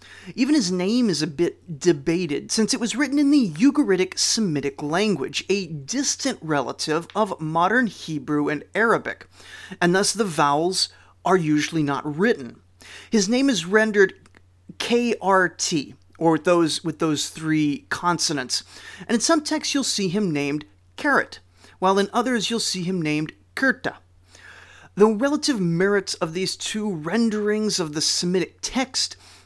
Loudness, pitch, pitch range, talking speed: -22 LUFS, 180 Hz, 155-220 Hz, 145 wpm